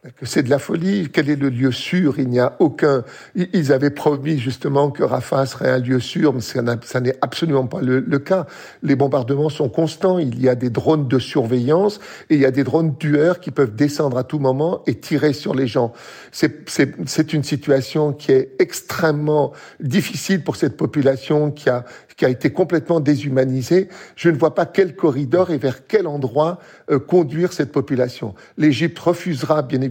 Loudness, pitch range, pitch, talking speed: -19 LUFS, 135-165 Hz, 150 Hz, 195 wpm